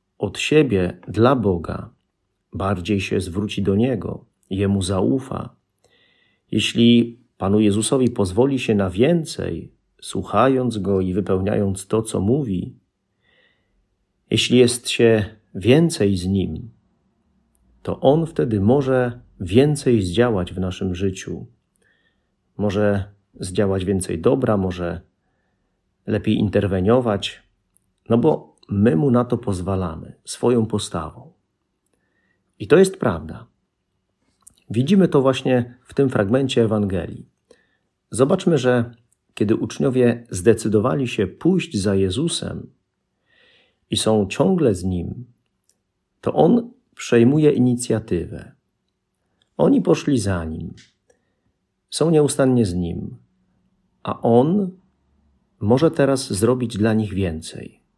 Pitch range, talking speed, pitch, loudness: 95-125 Hz, 105 wpm, 110 Hz, -20 LUFS